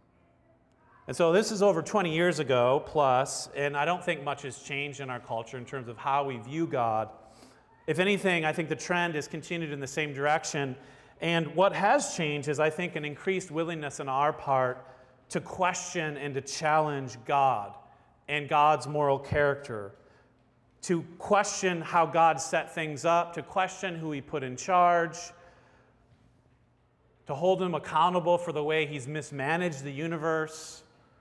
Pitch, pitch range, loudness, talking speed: 150 Hz, 135-170 Hz, -29 LUFS, 165 wpm